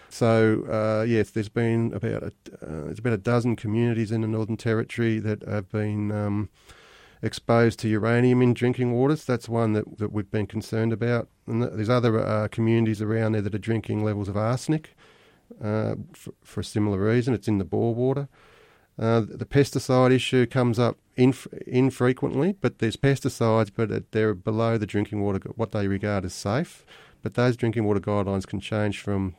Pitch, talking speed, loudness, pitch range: 115 Hz, 185 wpm, -25 LUFS, 105-120 Hz